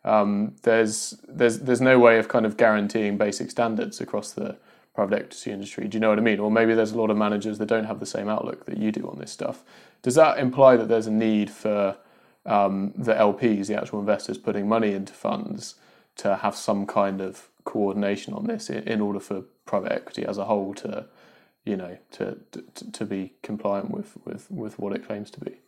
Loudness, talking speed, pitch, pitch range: -24 LUFS, 220 wpm, 105 Hz, 100-115 Hz